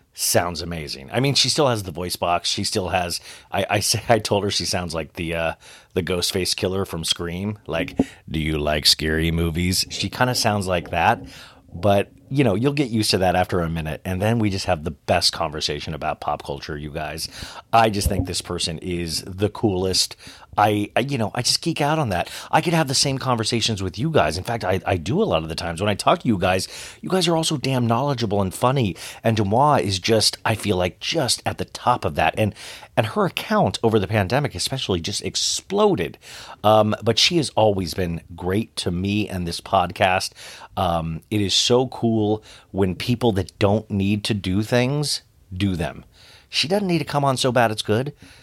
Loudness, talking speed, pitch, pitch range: -21 LUFS, 220 wpm, 100 Hz, 90-115 Hz